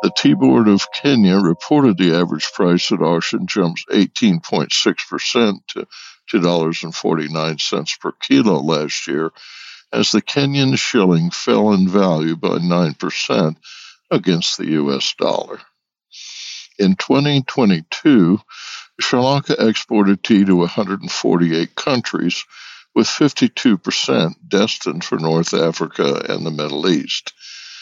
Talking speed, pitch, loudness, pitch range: 110 wpm, 90 Hz, -16 LUFS, 80-105 Hz